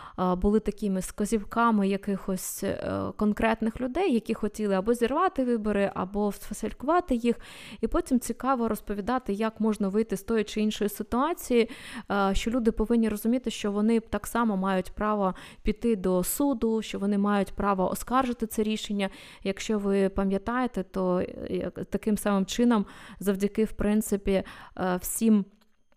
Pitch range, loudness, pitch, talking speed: 200-230 Hz, -28 LUFS, 215 Hz, 130 wpm